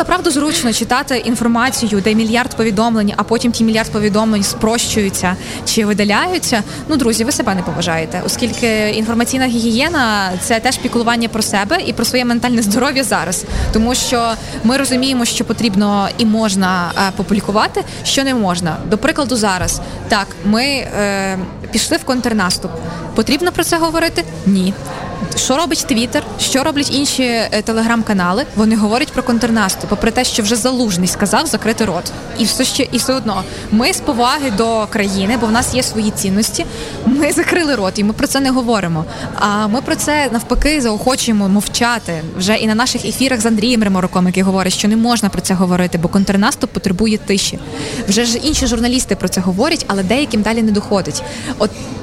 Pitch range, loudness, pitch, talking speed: 200-250 Hz, -15 LUFS, 225 Hz, 170 wpm